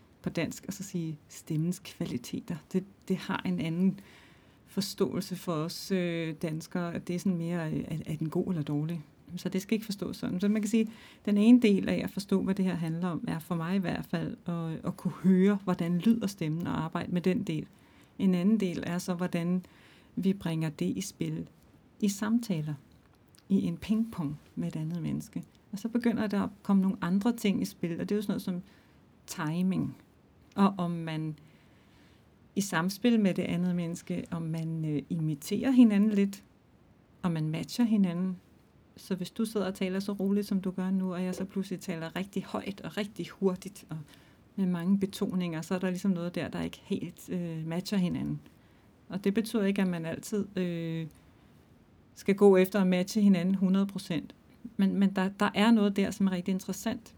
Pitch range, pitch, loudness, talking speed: 170-200 Hz, 185 Hz, -31 LUFS, 195 wpm